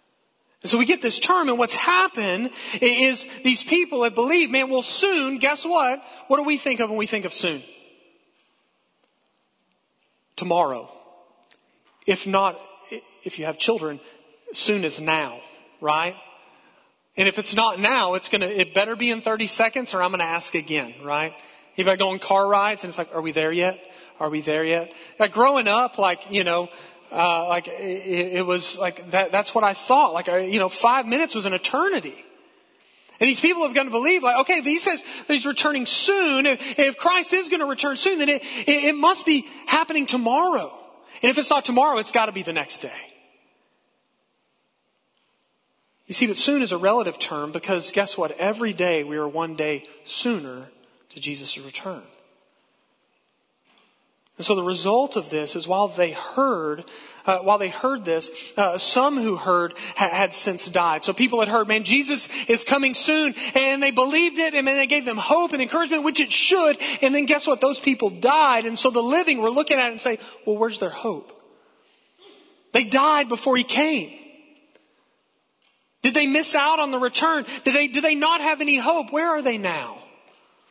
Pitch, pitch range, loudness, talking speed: 235 Hz, 185-285 Hz, -21 LUFS, 190 wpm